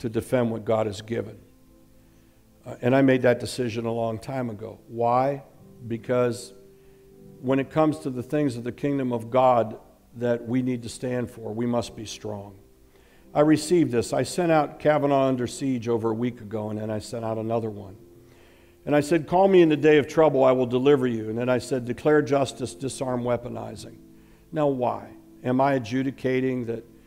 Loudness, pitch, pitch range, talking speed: -24 LUFS, 120 Hz, 115-135 Hz, 195 wpm